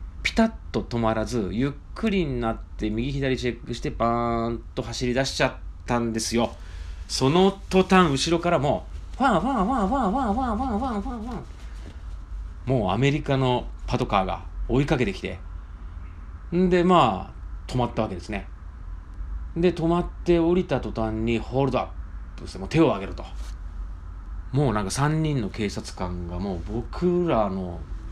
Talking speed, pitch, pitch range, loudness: 310 characters per minute, 115 Hz, 85-145 Hz, -25 LUFS